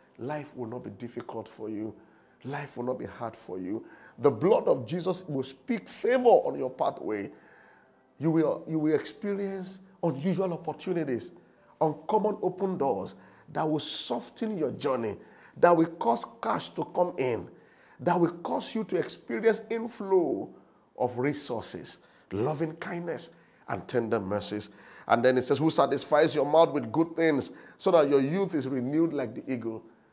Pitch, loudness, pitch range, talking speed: 155 Hz, -29 LUFS, 125-175 Hz, 160 wpm